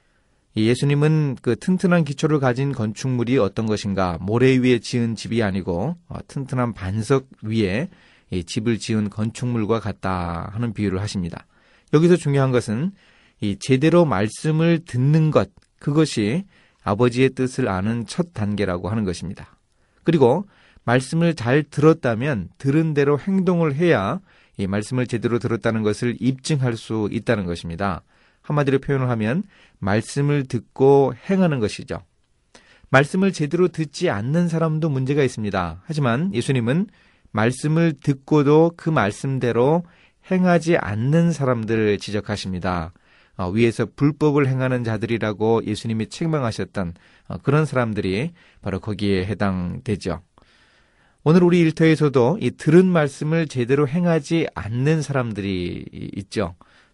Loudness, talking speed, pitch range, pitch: -21 LUFS, 300 characters per minute, 105-155 Hz, 125 Hz